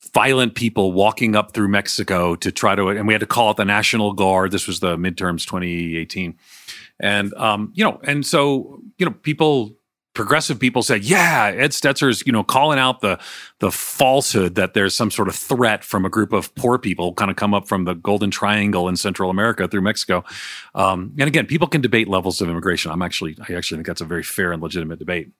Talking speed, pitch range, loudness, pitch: 215 wpm, 95-125 Hz, -18 LUFS, 100 Hz